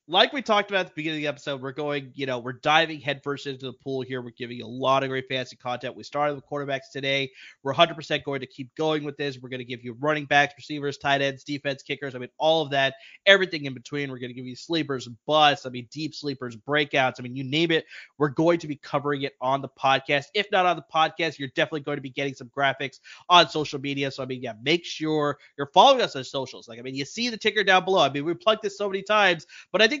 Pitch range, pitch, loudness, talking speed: 135-155 Hz, 140 Hz, -25 LUFS, 275 wpm